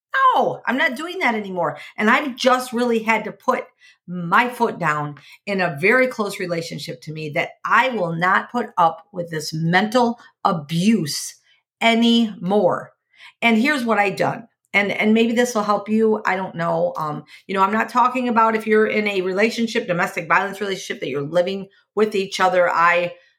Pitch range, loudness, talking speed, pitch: 175-230 Hz, -19 LUFS, 180 wpm, 205 Hz